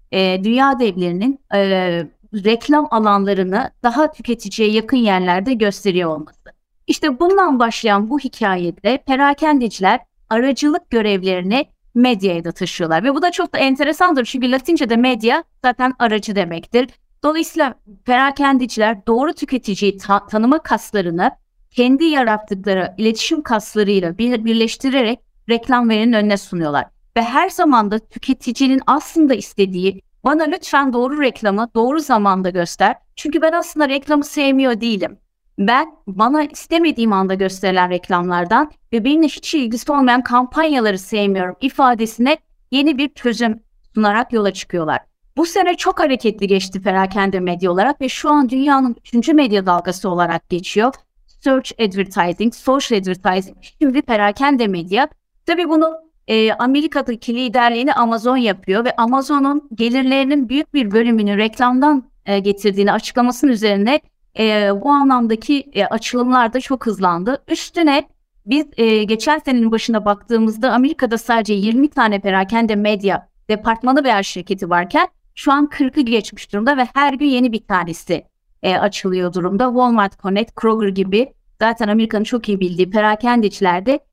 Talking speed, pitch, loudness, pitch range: 125 wpm, 235 Hz, -16 LUFS, 200-275 Hz